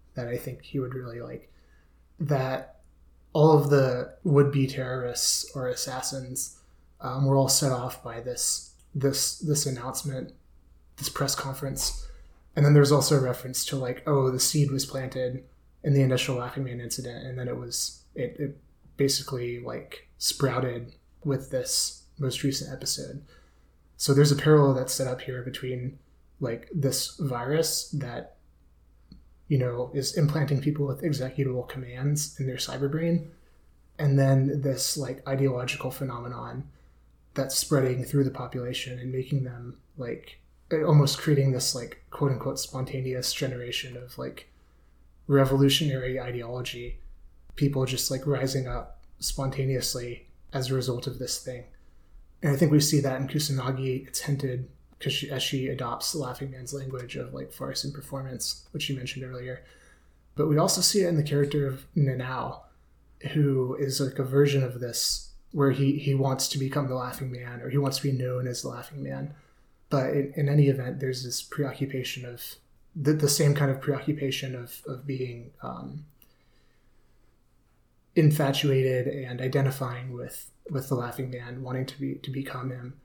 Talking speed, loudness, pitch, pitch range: 160 wpm, -27 LUFS, 130 Hz, 125-140 Hz